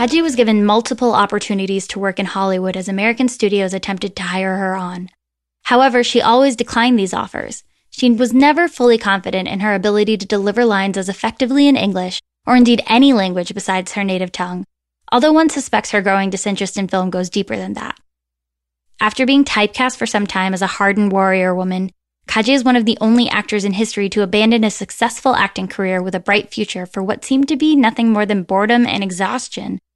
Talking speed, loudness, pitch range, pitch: 200 wpm, -15 LUFS, 190-240 Hz, 205 Hz